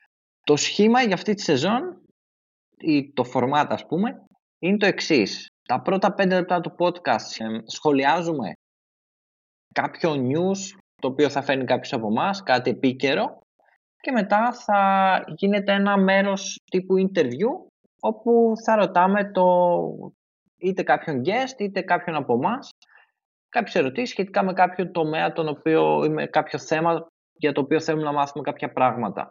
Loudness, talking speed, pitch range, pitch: -22 LUFS, 145 wpm, 145-200 Hz, 175 Hz